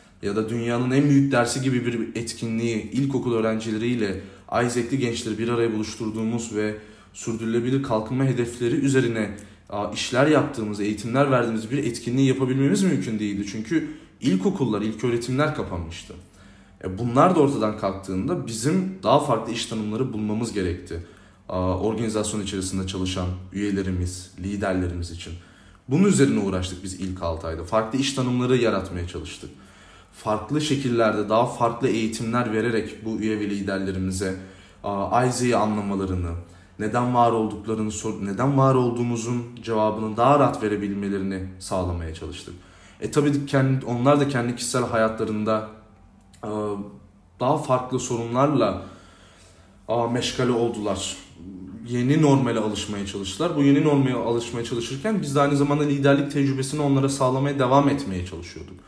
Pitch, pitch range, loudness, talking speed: 110 Hz, 95-125 Hz, -23 LUFS, 125 wpm